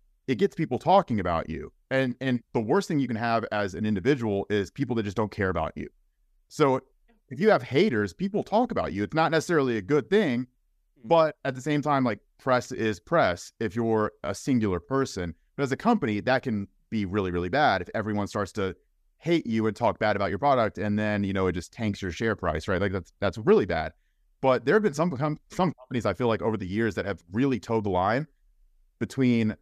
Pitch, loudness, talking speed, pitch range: 115 Hz, -27 LUFS, 225 wpm, 100-140 Hz